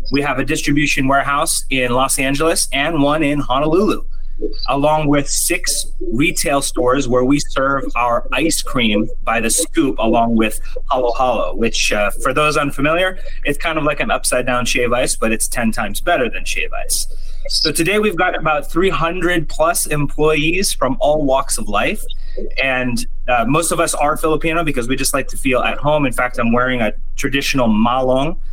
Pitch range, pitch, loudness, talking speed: 130-165 Hz, 145 Hz, -16 LUFS, 185 wpm